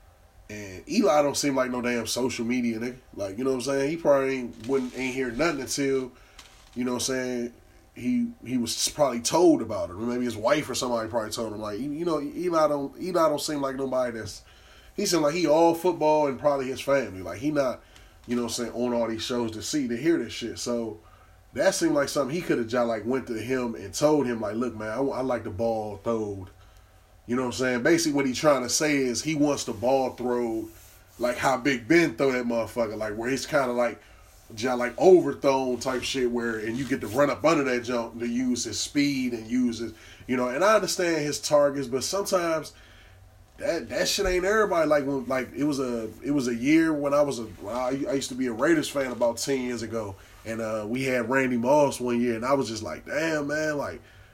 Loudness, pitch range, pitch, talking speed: -26 LUFS, 115-145 Hz, 125 Hz, 235 wpm